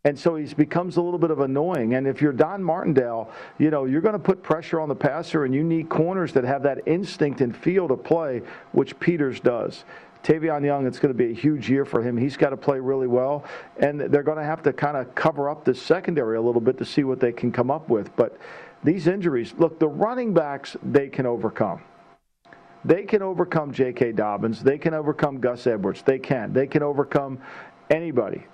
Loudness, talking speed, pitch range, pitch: -23 LUFS, 220 wpm, 130-160 Hz, 145 Hz